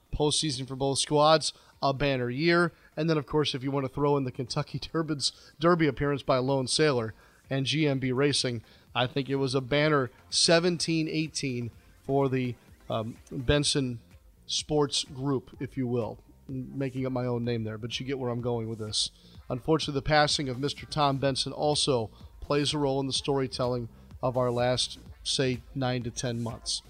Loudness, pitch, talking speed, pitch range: -28 LUFS, 135 Hz, 185 wpm, 125-145 Hz